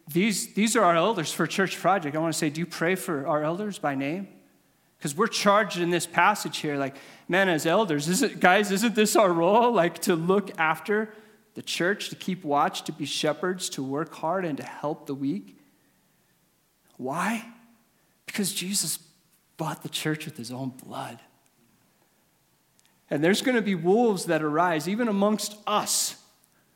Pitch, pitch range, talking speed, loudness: 175 Hz, 155-205 Hz, 175 wpm, -25 LUFS